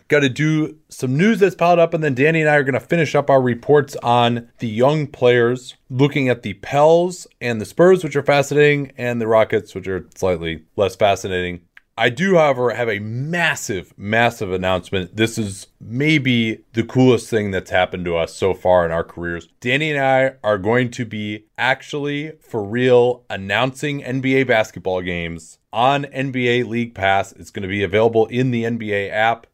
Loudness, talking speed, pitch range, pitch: -18 LUFS, 185 wpm, 105-140 Hz, 120 Hz